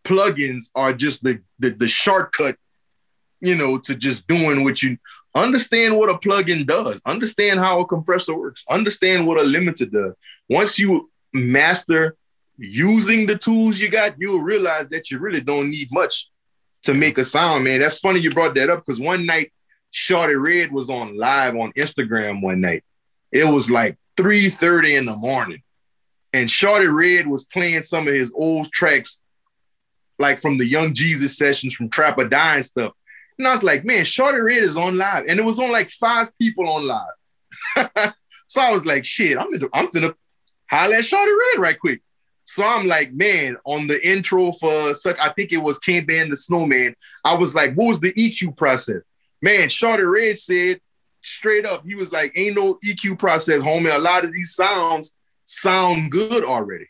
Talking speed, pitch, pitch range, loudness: 185 wpm, 165 Hz, 140-200 Hz, -18 LUFS